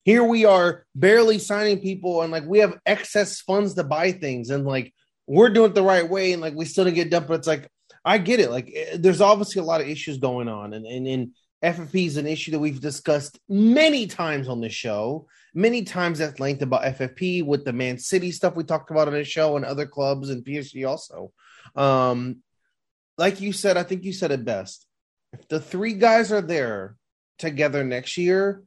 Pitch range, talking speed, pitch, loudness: 140-190 Hz, 220 wpm, 165 Hz, -22 LUFS